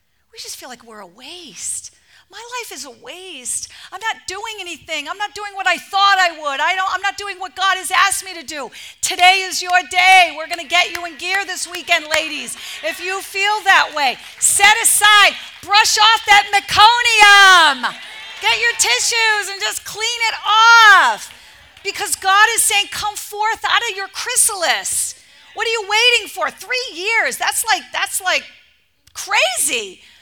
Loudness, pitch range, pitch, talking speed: -14 LUFS, 360-430 Hz, 390 Hz, 180 wpm